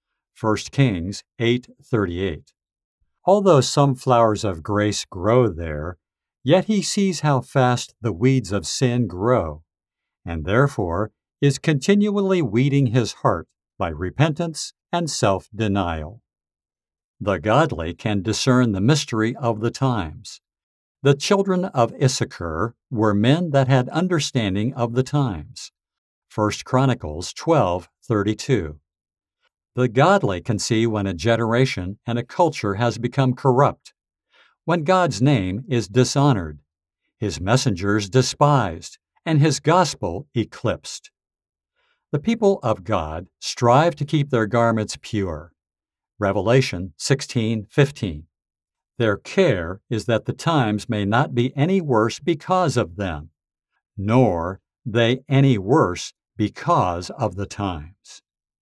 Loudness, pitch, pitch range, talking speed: -21 LUFS, 115 Hz, 100-140 Hz, 115 wpm